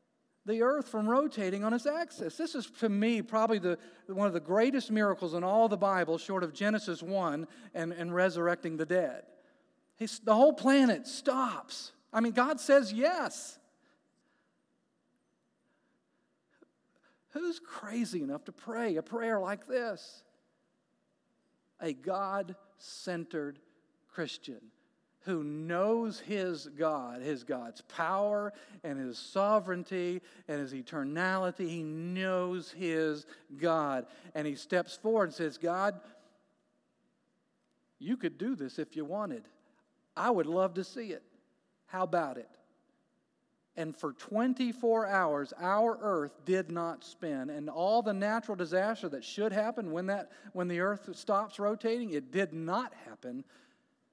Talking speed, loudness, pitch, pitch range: 135 wpm, -33 LUFS, 200 Hz, 175-240 Hz